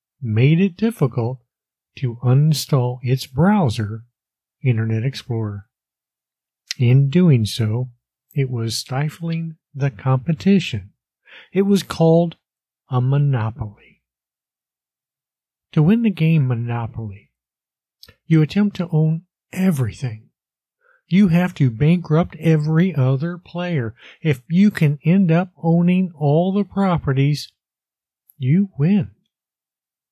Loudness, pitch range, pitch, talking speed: -19 LUFS, 110-165 Hz, 135 Hz, 100 wpm